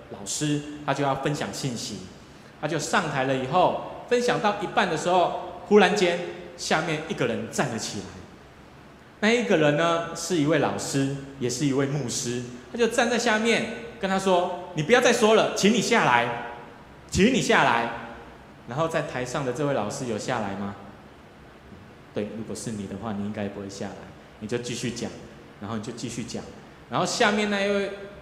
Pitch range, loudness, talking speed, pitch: 120-200 Hz, -25 LUFS, 260 characters per minute, 145 Hz